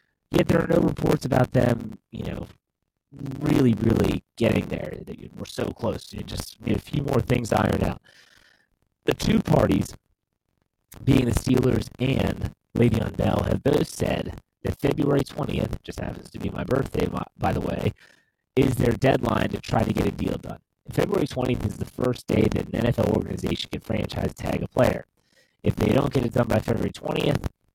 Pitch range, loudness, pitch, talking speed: 100-130 Hz, -25 LUFS, 115 Hz, 175 wpm